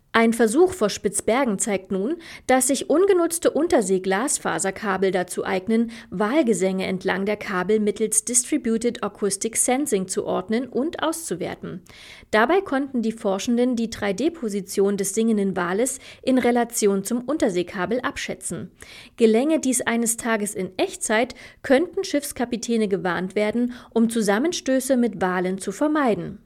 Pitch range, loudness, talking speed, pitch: 200-260 Hz, -22 LUFS, 120 wpm, 225 Hz